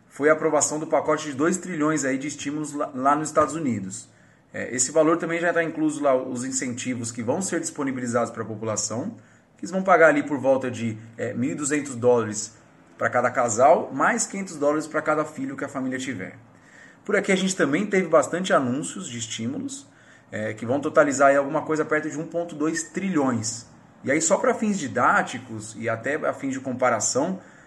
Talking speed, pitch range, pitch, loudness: 185 wpm, 125-165 Hz, 150 Hz, -23 LUFS